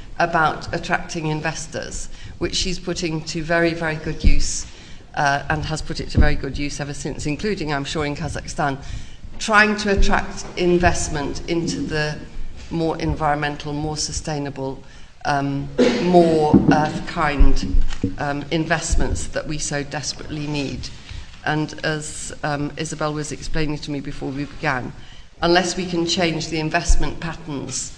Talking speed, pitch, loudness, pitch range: 140 wpm, 155 Hz, -22 LUFS, 145-165 Hz